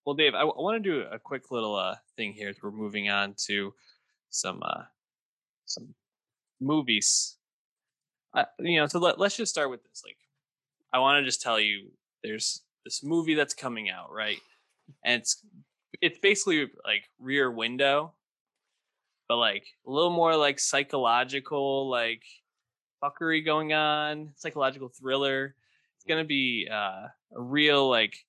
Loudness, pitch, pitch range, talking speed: -27 LUFS, 140 Hz, 120-155 Hz, 155 wpm